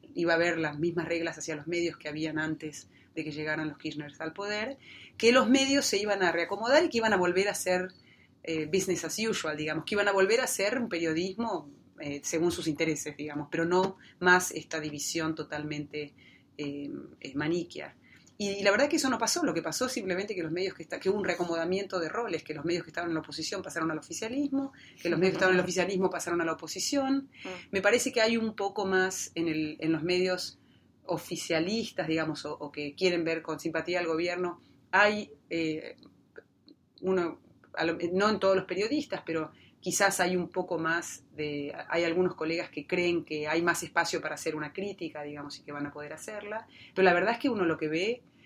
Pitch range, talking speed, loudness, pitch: 160-190 Hz, 215 wpm, -30 LUFS, 170 Hz